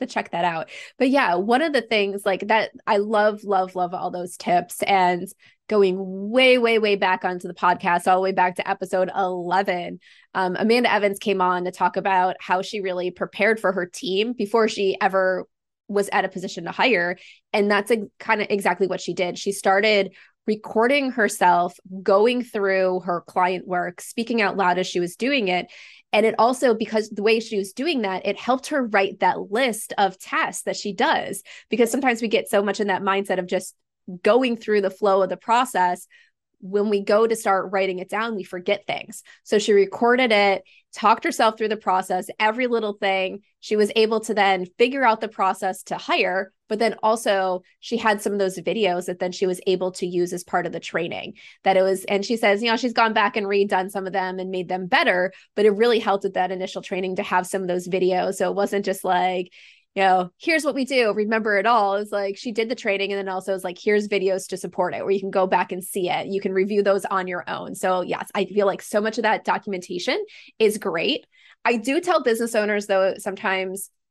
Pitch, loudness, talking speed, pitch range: 195 Hz, -22 LUFS, 225 wpm, 185-220 Hz